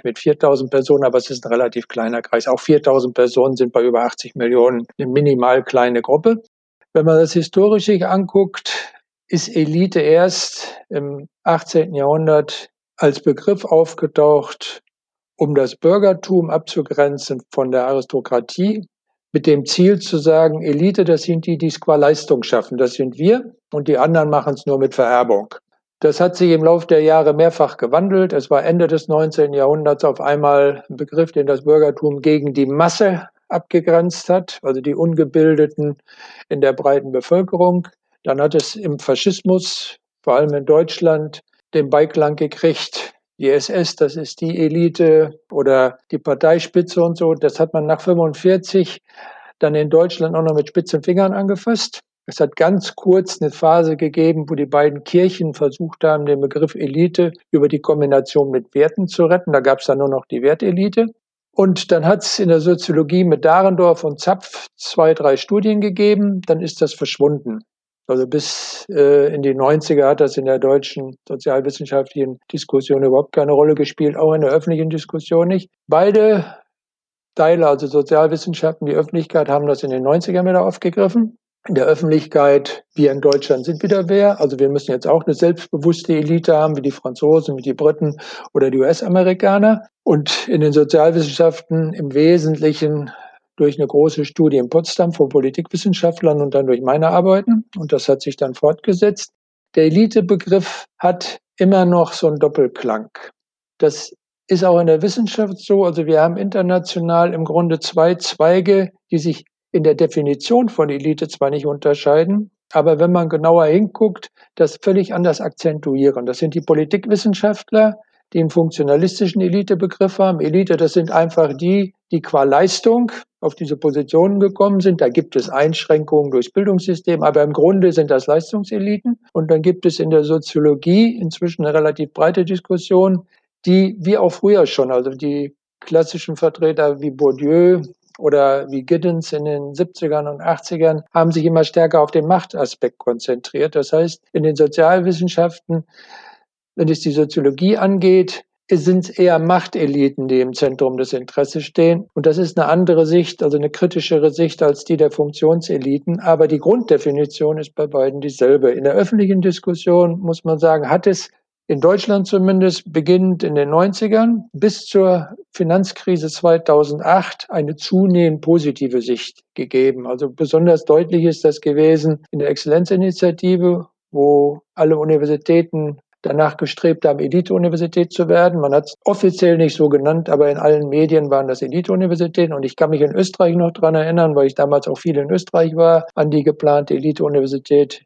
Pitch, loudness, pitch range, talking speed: 160 Hz, -16 LUFS, 145-180 Hz, 165 wpm